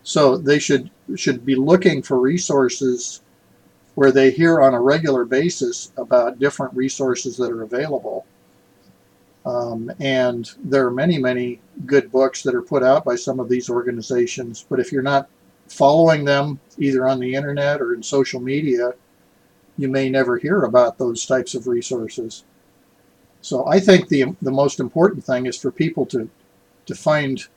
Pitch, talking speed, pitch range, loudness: 130 Hz, 165 wpm, 120-140 Hz, -19 LUFS